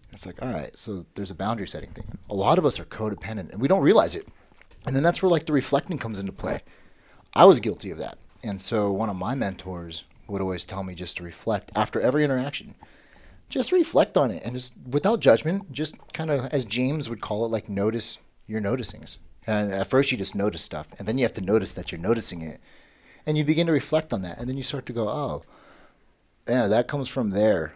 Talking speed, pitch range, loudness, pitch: 235 wpm, 95-135 Hz, -25 LUFS, 110 Hz